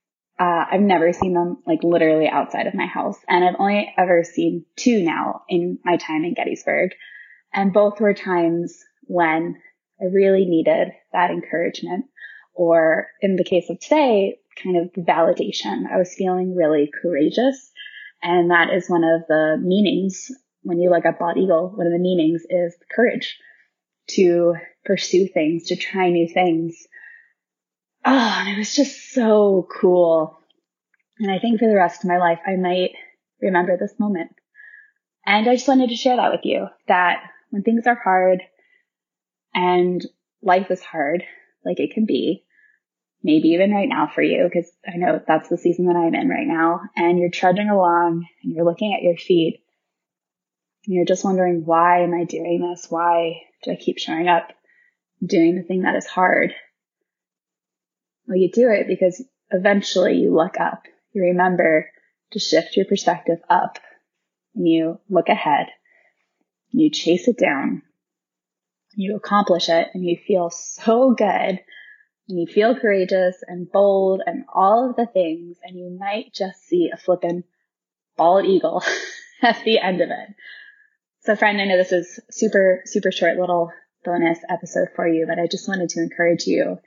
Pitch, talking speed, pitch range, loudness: 185 Hz, 170 wpm, 170-215 Hz, -19 LUFS